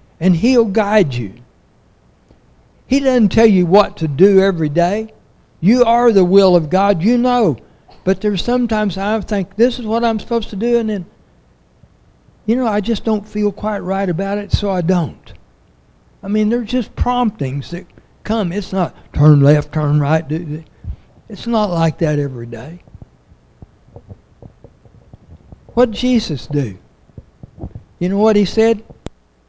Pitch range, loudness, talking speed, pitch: 155-220 Hz, -15 LUFS, 155 wpm, 195 Hz